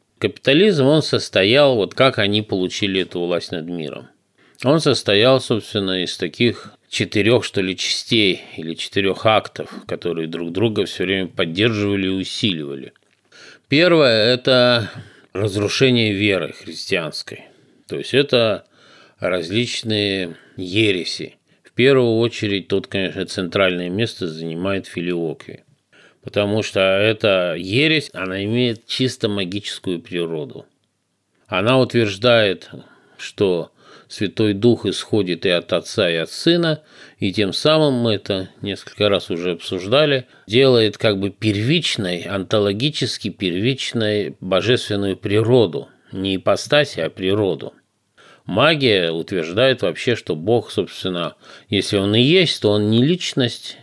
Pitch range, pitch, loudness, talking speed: 95-120 Hz, 105 Hz, -18 LUFS, 120 wpm